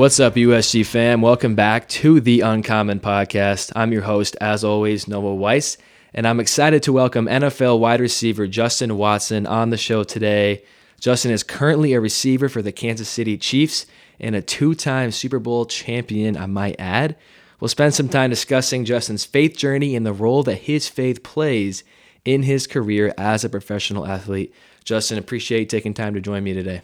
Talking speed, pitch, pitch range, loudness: 185 wpm, 115 Hz, 105-130 Hz, -19 LUFS